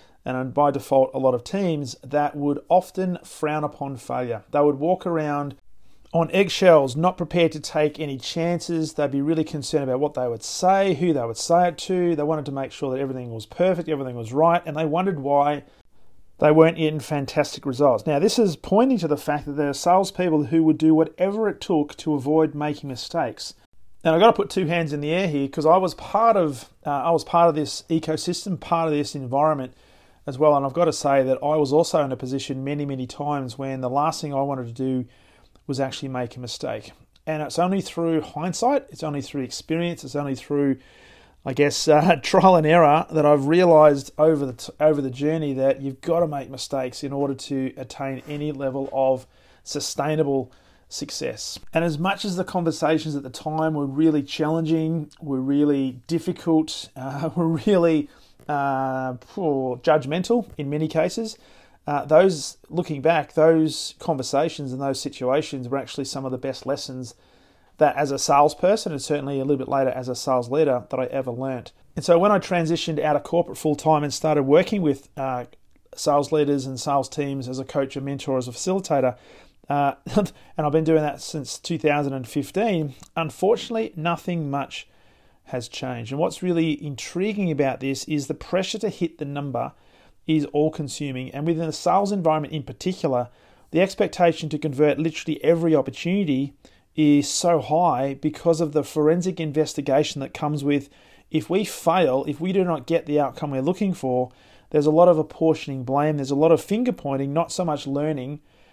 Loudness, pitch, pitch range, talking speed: -22 LUFS, 150 Hz, 135-165 Hz, 195 wpm